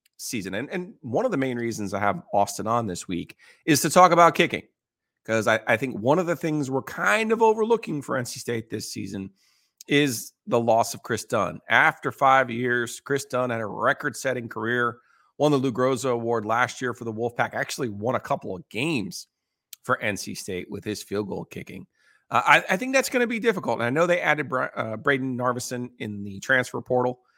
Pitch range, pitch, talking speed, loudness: 115-145 Hz, 125 Hz, 215 wpm, -24 LUFS